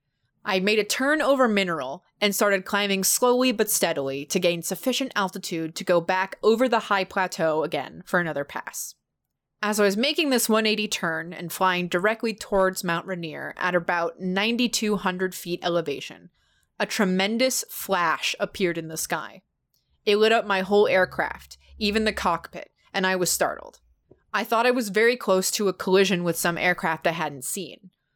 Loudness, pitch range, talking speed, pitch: -24 LUFS, 175-215 Hz, 170 wpm, 190 Hz